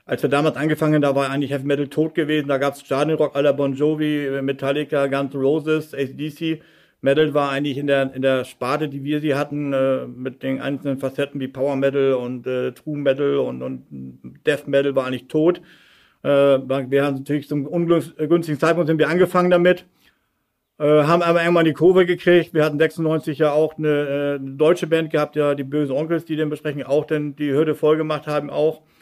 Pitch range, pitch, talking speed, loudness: 140-155 Hz, 145 Hz, 205 wpm, -20 LUFS